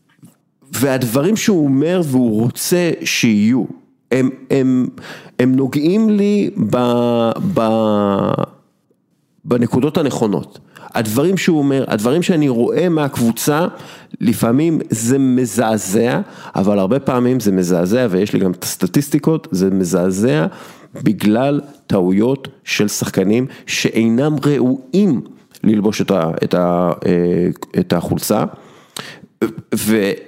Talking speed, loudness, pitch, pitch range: 105 wpm, -16 LUFS, 125 Hz, 105-145 Hz